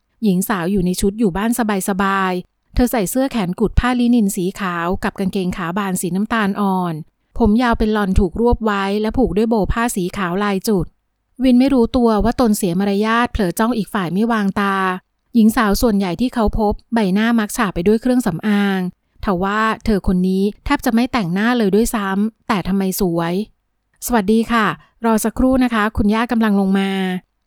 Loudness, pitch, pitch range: -17 LUFS, 210 Hz, 195-230 Hz